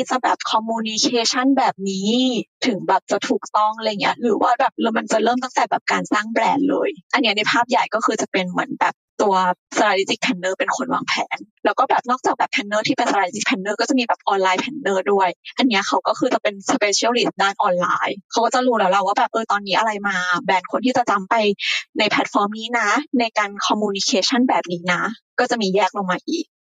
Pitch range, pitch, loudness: 195-250 Hz, 220 Hz, -19 LUFS